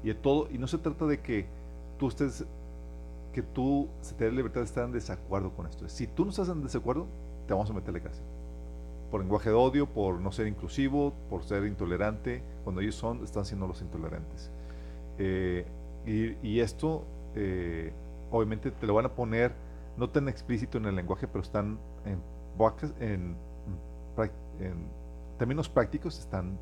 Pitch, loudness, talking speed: 95 Hz, -33 LUFS, 170 wpm